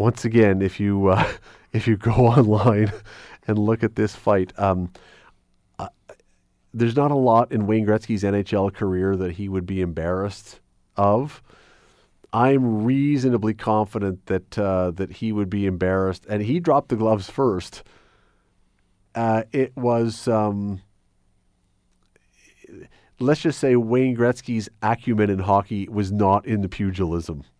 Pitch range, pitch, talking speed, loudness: 95-115 Hz, 105 Hz, 140 wpm, -21 LUFS